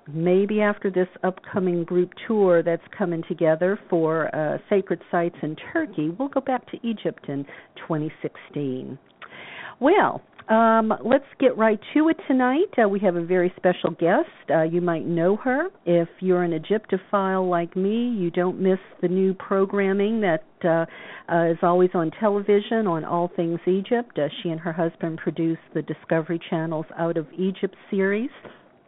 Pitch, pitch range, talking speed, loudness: 180 Hz, 170-205 Hz, 160 wpm, -23 LUFS